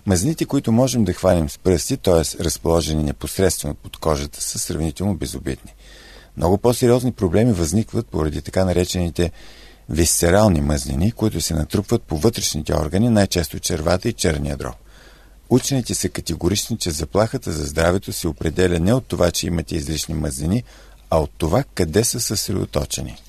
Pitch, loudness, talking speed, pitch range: 90 Hz, -20 LUFS, 145 wpm, 80-105 Hz